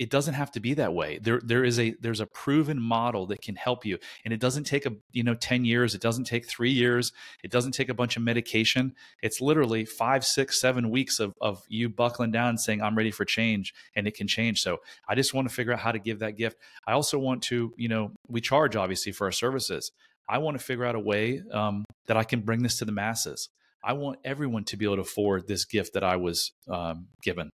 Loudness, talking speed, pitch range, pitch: -28 LUFS, 250 wpm, 110-130 Hz, 115 Hz